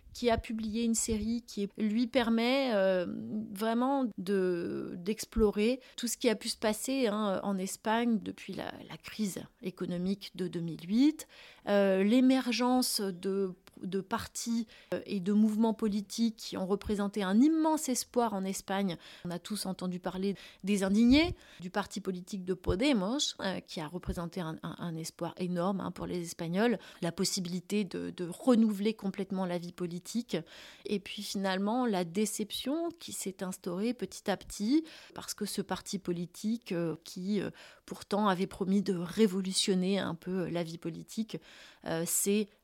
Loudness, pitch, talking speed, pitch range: -32 LUFS, 200 Hz, 150 wpm, 185-230 Hz